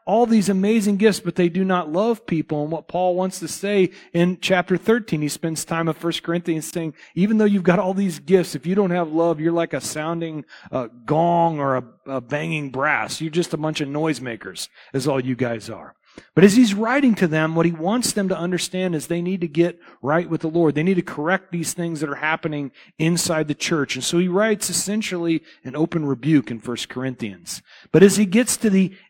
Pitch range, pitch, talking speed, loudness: 150-190 Hz, 170 Hz, 225 wpm, -21 LUFS